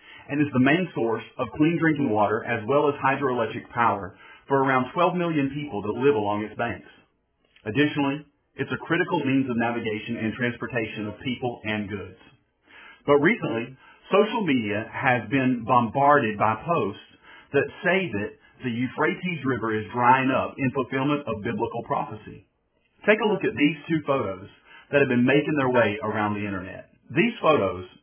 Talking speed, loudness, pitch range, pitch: 165 wpm, -24 LUFS, 110-145 Hz, 130 Hz